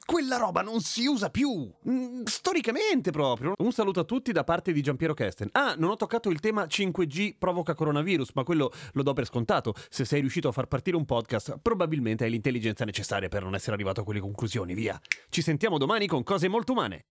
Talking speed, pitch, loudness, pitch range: 205 wpm, 165 Hz, -28 LUFS, 130-215 Hz